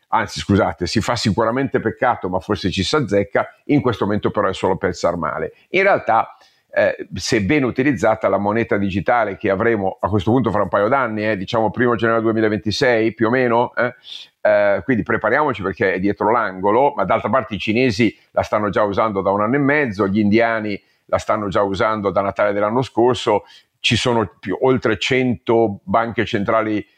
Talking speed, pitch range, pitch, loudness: 185 wpm, 100-120 Hz, 110 Hz, -18 LUFS